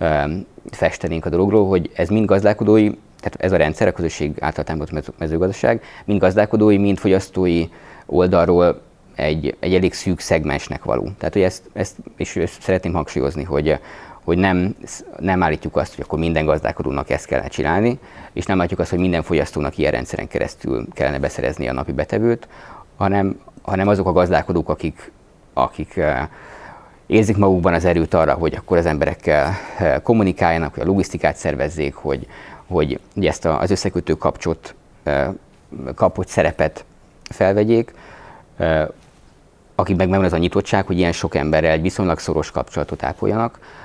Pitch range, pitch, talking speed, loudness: 80-100 Hz, 90 Hz, 150 wpm, -19 LUFS